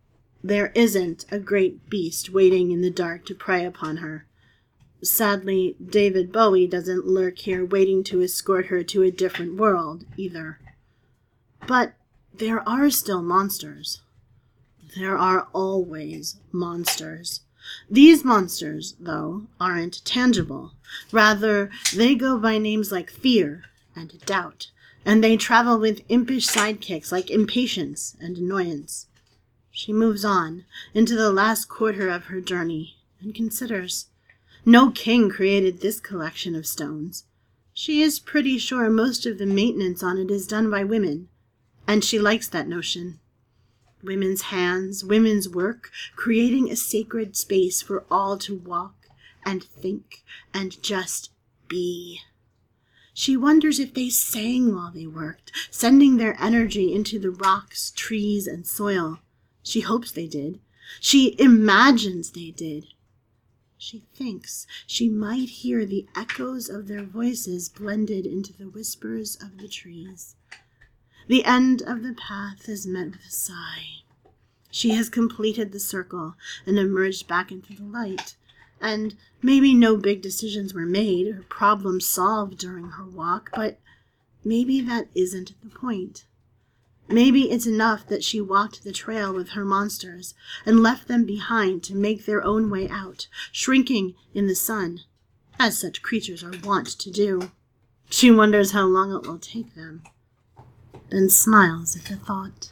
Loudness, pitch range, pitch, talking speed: -22 LUFS, 175-220 Hz, 195 Hz, 140 wpm